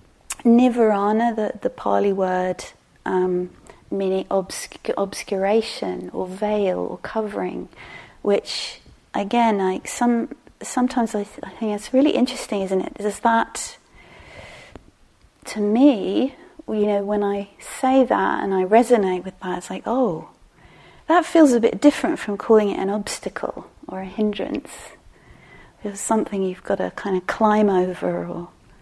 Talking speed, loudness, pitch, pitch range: 140 wpm, -21 LUFS, 210 Hz, 190-235 Hz